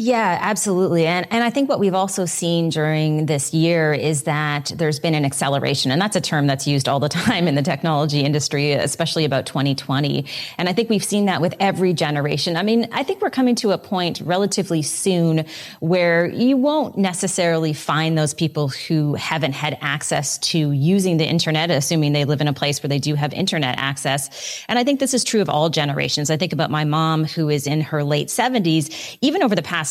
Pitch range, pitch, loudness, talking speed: 150-185 Hz, 160 Hz, -19 LUFS, 215 wpm